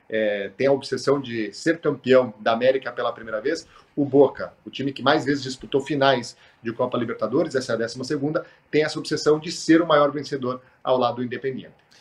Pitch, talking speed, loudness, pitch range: 135 Hz, 205 wpm, -23 LUFS, 125-145 Hz